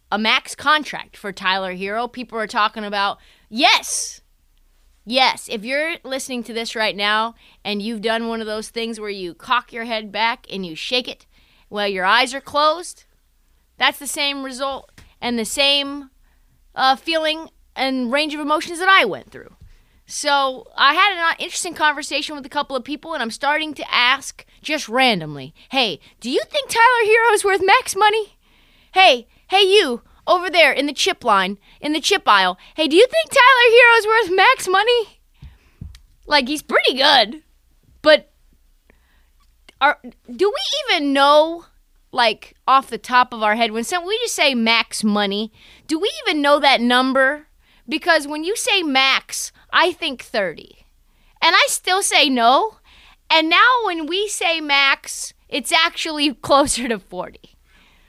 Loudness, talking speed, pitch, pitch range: -17 LUFS, 165 wpm, 280 Hz, 230-330 Hz